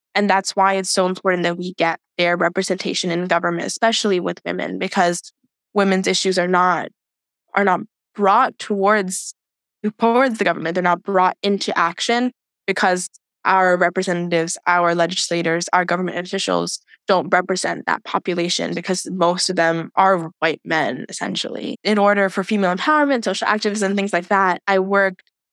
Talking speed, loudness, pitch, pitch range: 155 wpm, -19 LUFS, 185 Hz, 175-200 Hz